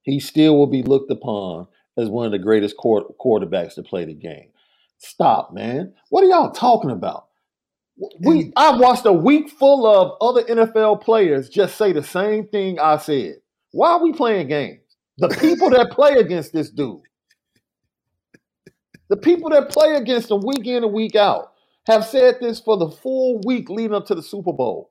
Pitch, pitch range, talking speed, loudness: 220 Hz, 165-275 Hz, 180 wpm, -17 LUFS